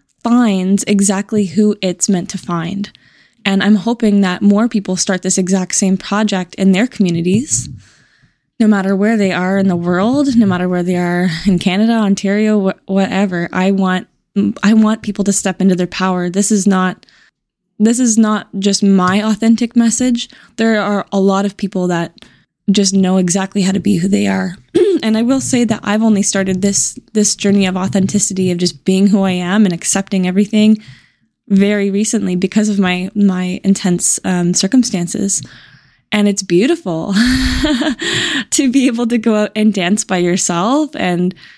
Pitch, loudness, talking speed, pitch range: 200 Hz, -14 LUFS, 175 wpm, 185-215 Hz